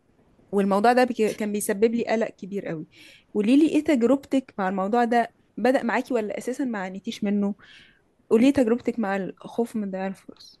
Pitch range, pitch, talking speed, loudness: 200-245 Hz, 230 Hz, 170 wpm, -24 LUFS